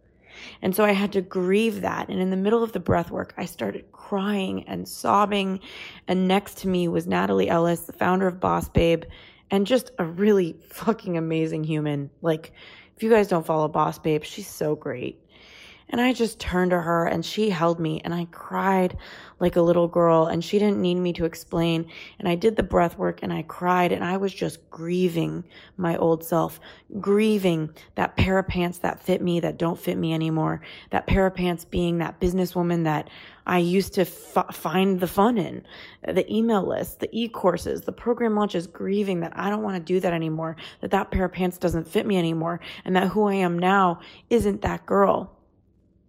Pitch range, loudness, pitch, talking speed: 165-195 Hz, -24 LUFS, 180 Hz, 200 wpm